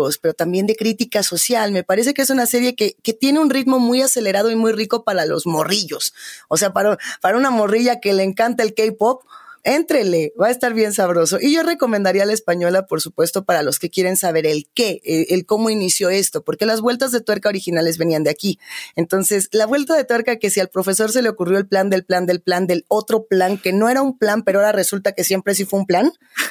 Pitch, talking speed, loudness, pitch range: 210 Hz, 240 wpm, -17 LUFS, 185-240 Hz